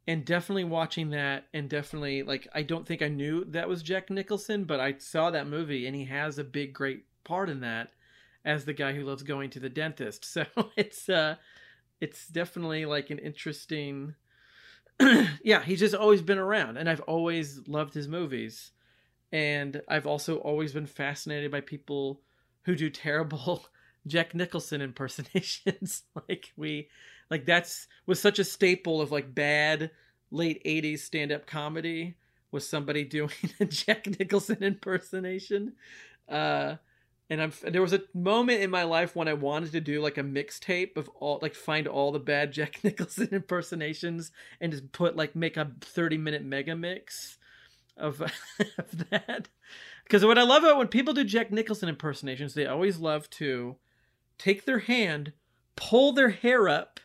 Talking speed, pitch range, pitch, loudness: 170 wpm, 145-185 Hz, 155 Hz, -29 LUFS